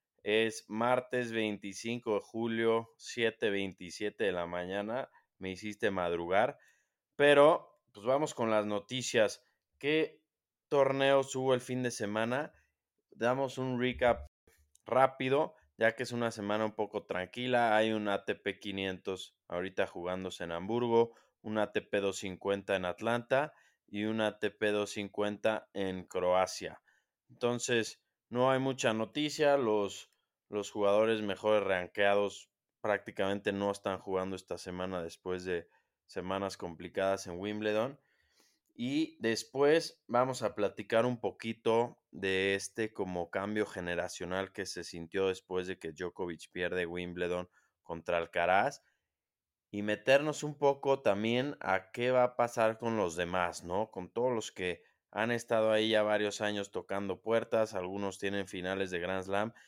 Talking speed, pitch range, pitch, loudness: 130 wpm, 95-120 Hz, 105 Hz, -33 LUFS